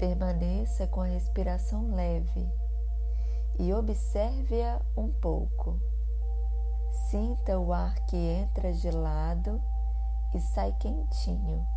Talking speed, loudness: 95 wpm, -31 LUFS